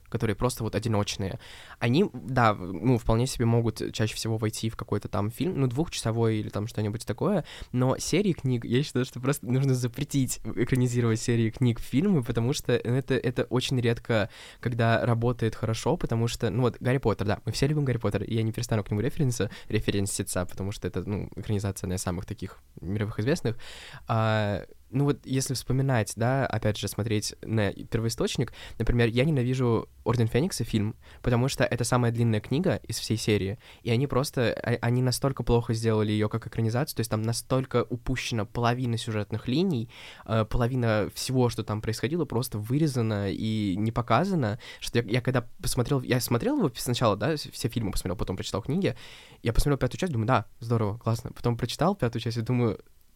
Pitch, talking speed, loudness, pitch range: 115 Hz, 180 wpm, -28 LUFS, 110-125 Hz